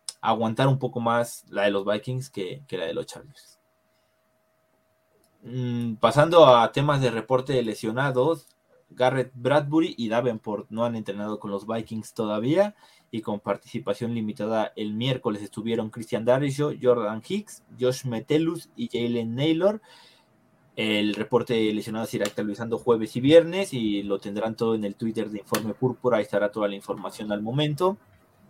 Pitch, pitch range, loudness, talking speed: 115 Hz, 110-130 Hz, -25 LUFS, 160 wpm